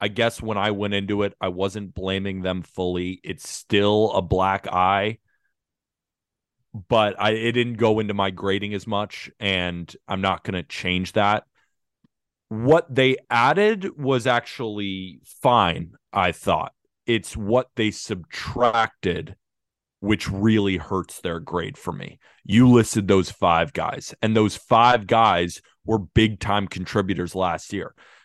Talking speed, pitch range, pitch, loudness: 145 wpm, 95-110 Hz, 105 Hz, -22 LUFS